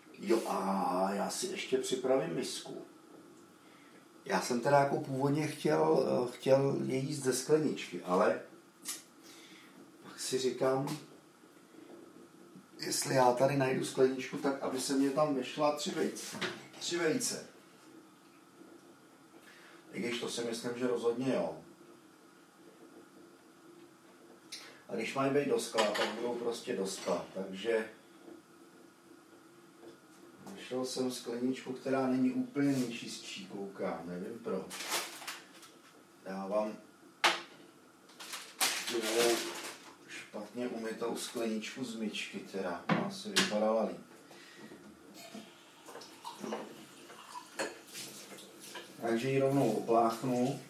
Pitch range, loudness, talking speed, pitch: 115-135 Hz, -34 LUFS, 100 wpm, 125 Hz